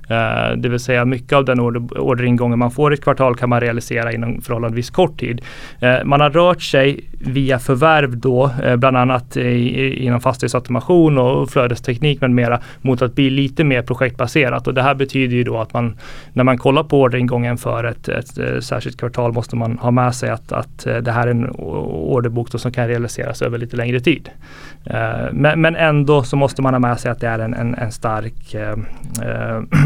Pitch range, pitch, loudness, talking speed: 120-135 Hz, 125 Hz, -17 LUFS, 190 wpm